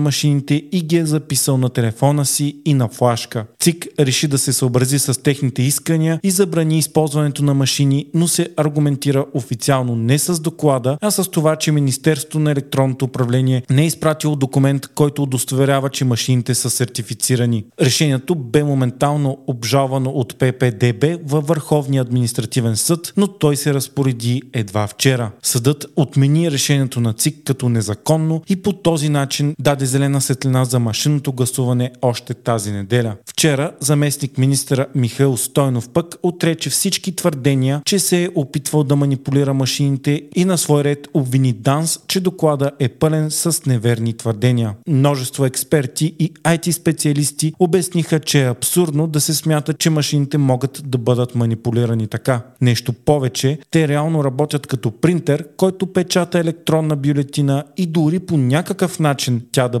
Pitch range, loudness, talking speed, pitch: 130-155 Hz, -17 LUFS, 150 wpm, 140 Hz